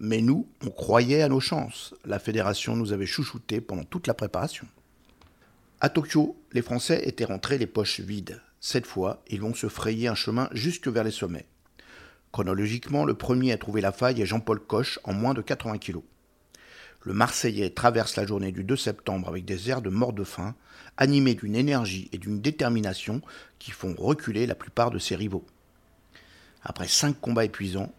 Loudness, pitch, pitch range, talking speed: -27 LUFS, 115 Hz, 100-130 Hz, 180 wpm